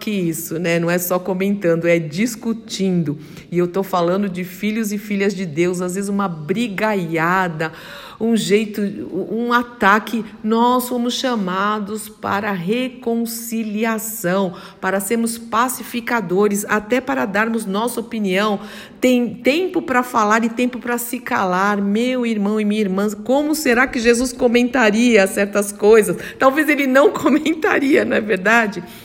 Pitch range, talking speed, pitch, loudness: 195-240 Hz, 140 wpm, 215 Hz, -18 LUFS